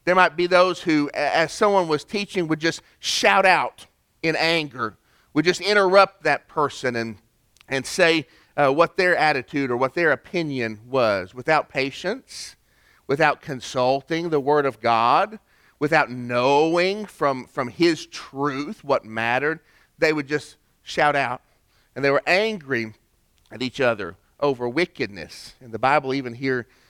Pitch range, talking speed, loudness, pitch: 130-170 Hz, 150 wpm, -22 LUFS, 150 Hz